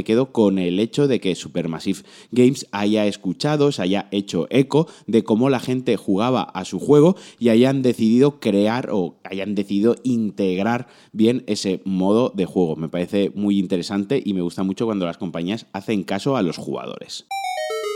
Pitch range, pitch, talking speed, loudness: 95-130 Hz, 105 Hz, 175 wpm, -20 LUFS